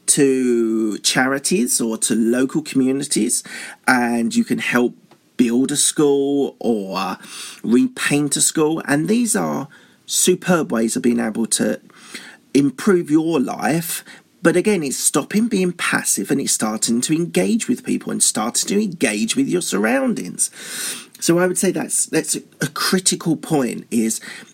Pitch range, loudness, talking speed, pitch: 125-190 Hz, -18 LUFS, 145 wpm, 150 Hz